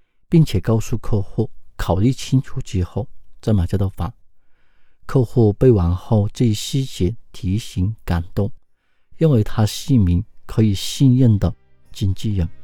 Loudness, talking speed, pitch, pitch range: -19 LUFS, 210 characters per minute, 105 Hz, 95-120 Hz